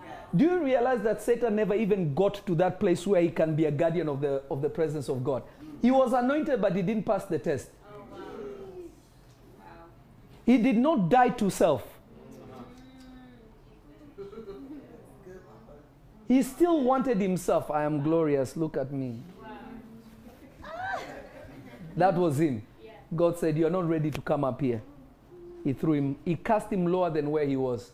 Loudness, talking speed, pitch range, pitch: -27 LUFS, 155 wpm, 145-220 Hz, 175 Hz